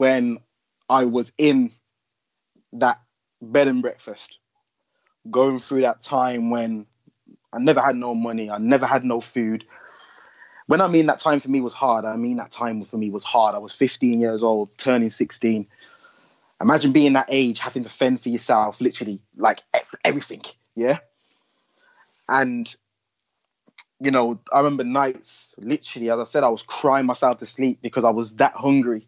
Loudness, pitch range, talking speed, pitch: -21 LUFS, 115-135 Hz, 165 wpm, 125 Hz